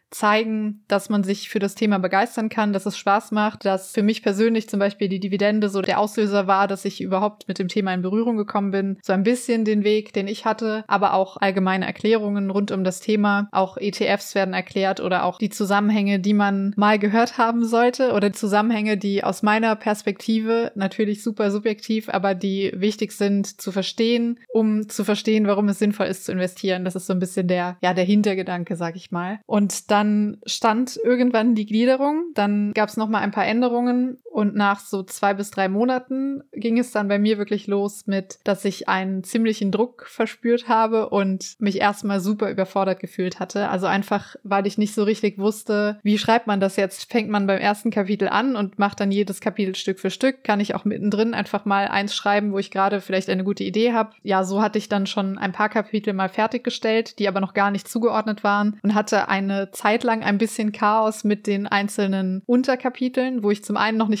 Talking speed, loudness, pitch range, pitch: 210 wpm, -22 LUFS, 195-220 Hz, 205 Hz